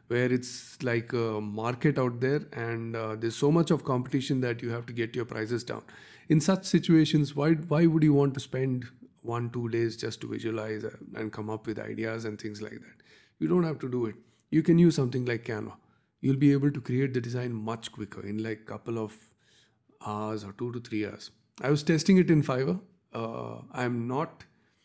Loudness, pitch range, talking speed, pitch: -29 LUFS, 110-145 Hz, 210 wpm, 120 Hz